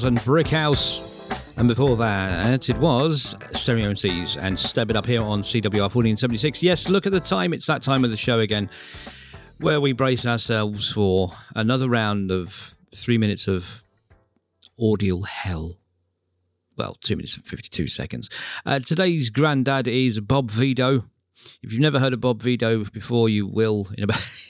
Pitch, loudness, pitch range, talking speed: 115 Hz, -21 LUFS, 100-130 Hz, 175 wpm